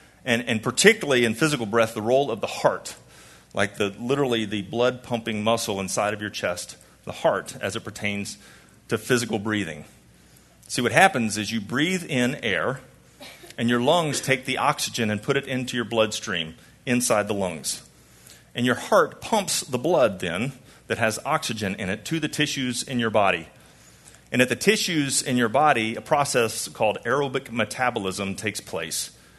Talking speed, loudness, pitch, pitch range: 175 wpm, -24 LUFS, 115 Hz, 110-130 Hz